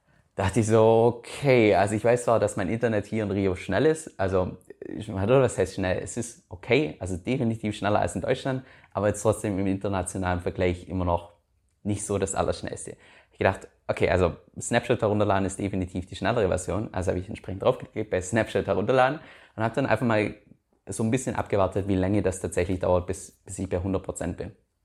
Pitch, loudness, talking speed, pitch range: 100 Hz, -26 LUFS, 195 wpm, 95-115 Hz